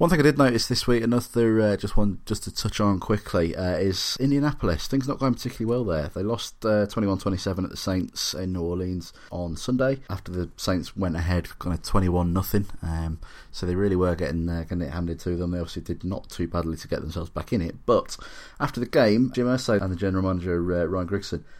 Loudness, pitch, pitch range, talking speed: -26 LUFS, 95 Hz, 85-110 Hz, 230 wpm